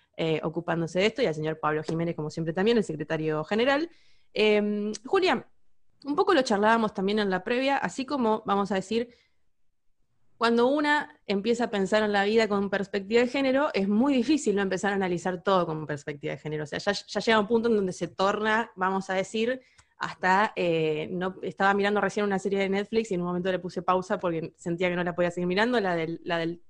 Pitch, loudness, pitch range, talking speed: 200 Hz, -27 LUFS, 180-225 Hz, 220 wpm